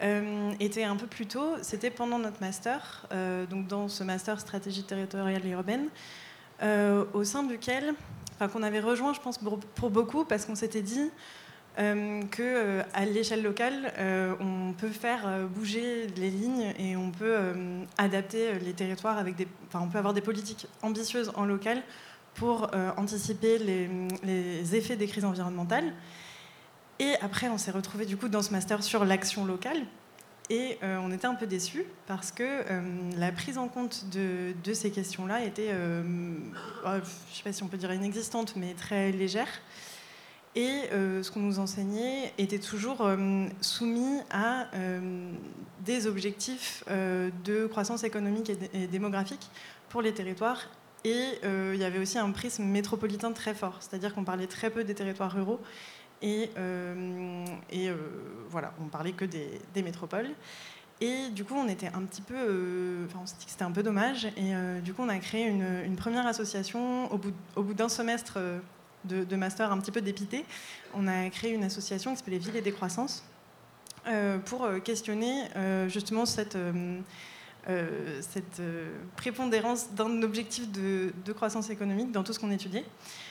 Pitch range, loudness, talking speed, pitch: 190-225 Hz, -32 LUFS, 180 wpm, 205 Hz